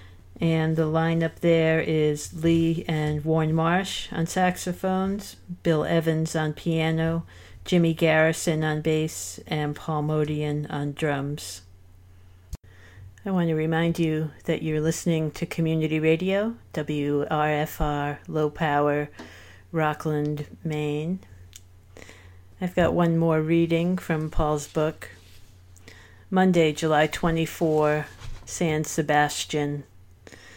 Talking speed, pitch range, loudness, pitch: 105 wpm, 145-165 Hz, -25 LUFS, 155 Hz